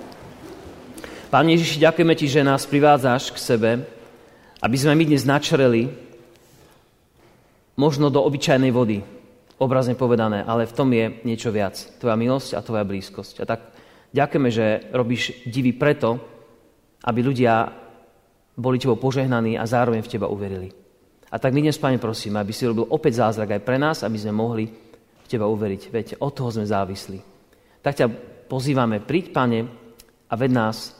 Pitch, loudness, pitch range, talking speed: 120 Hz, -21 LUFS, 110-135 Hz, 155 wpm